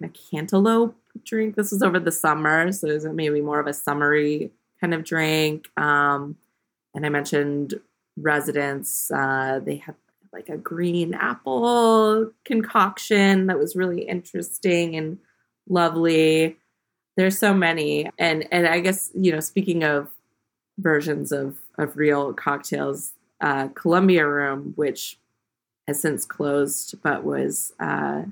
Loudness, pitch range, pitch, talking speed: -22 LUFS, 145-185 Hz, 155 Hz, 135 wpm